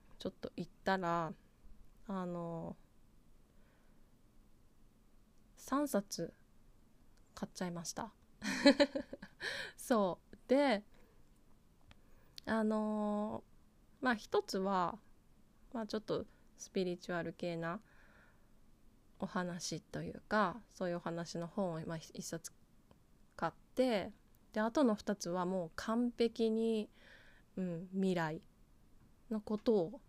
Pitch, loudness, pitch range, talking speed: 190 Hz, -38 LUFS, 170-220 Hz, 170 characters per minute